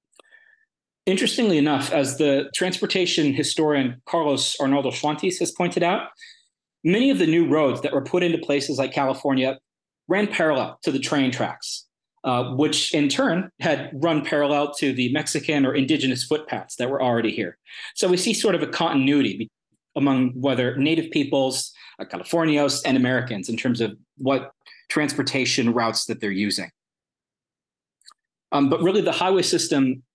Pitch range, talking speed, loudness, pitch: 130-165 Hz, 150 wpm, -22 LUFS, 145 Hz